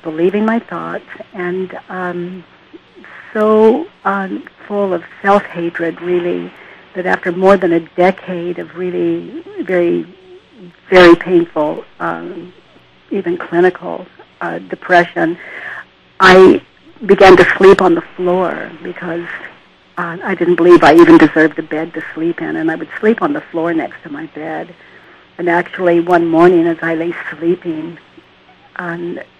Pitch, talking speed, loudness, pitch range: 180 Hz, 140 wpm, -12 LUFS, 170-195 Hz